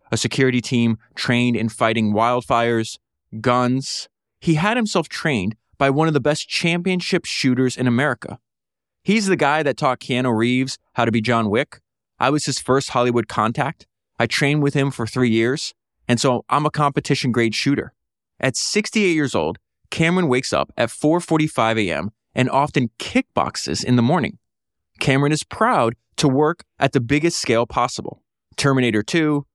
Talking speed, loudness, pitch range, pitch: 165 wpm, -20 LUFS, 120-150 Hz, 130 Hz